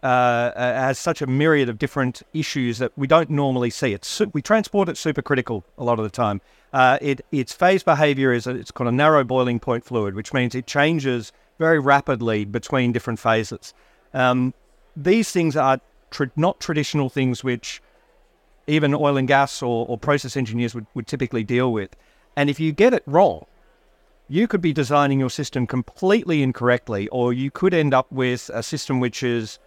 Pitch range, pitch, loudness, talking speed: 120-150 Hz, 130 Hz, -21 LUFS, 190 wpm